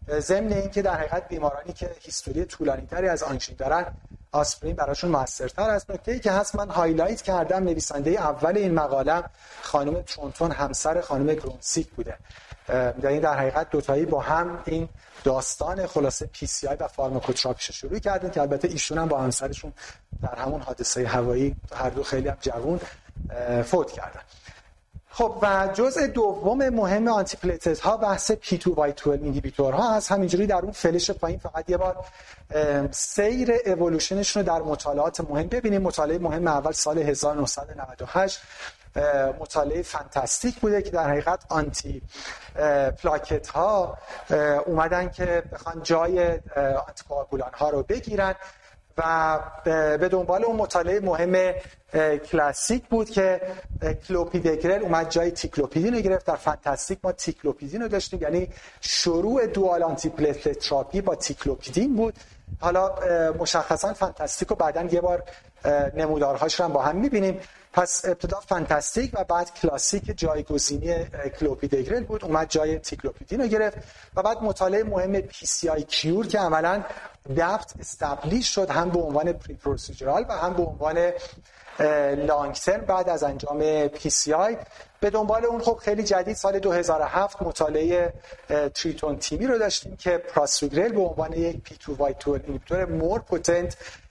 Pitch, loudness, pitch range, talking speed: 165 Hz, -25 LUFS, 145-190 Hz, 145 wpm